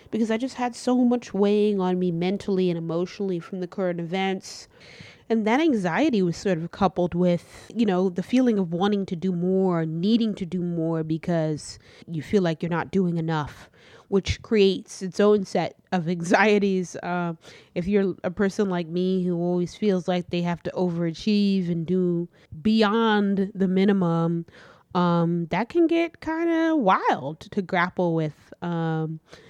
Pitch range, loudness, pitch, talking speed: 175-205 Hz, -24 LUFS, 185 Hz, 170 wpm